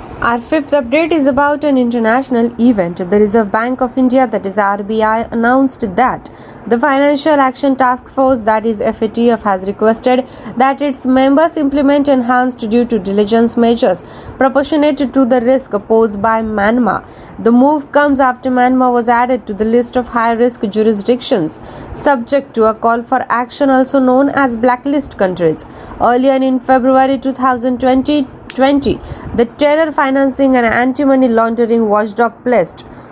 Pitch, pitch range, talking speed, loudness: 250 Hz, 230-270 Hz, 145 wpm, -12 LUFS